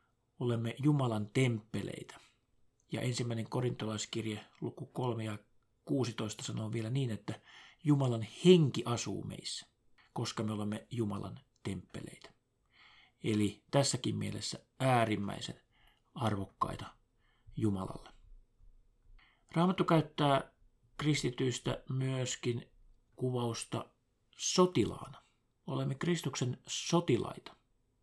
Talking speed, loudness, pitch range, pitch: 80 wpm, -35 LUFS, 110-135 Hz, 120 Hz